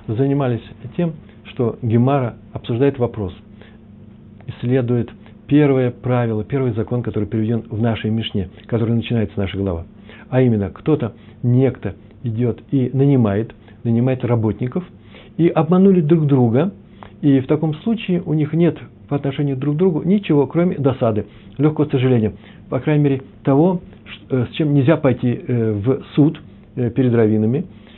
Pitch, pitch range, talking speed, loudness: 120 Hz, 110-140 Hz, 135 wpm, -18 LUFS